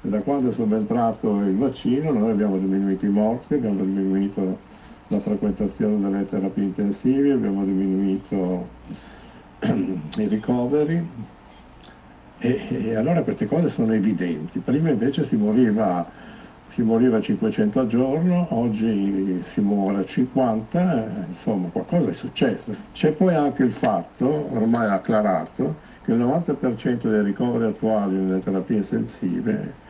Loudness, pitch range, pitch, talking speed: -22 LUFS, 95-140 Hz, 105 Hz, 130 wpm